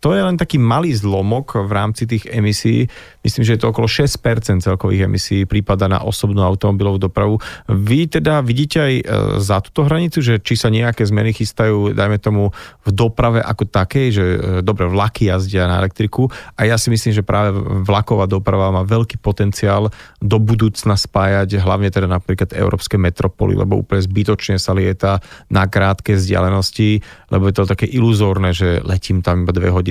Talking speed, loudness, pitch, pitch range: 175 wpm, -16 LUFS, 105 Hz, 95-115 Hz